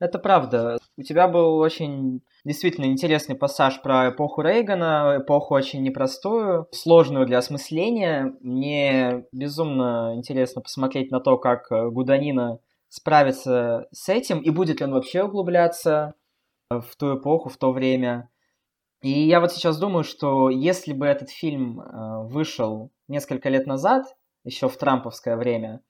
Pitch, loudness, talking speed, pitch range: 140 Hz, -22 LUFS, 135 wpm, 130-160 Hz